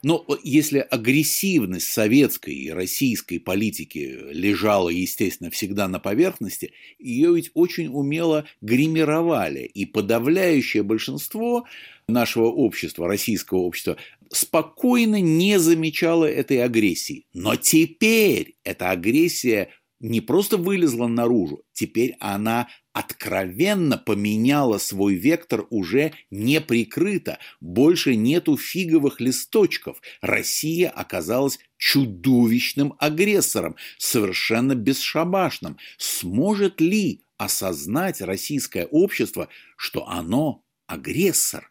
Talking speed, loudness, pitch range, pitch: 90 wpm, -21 LUFS, 120-180 Hz, 150 Hz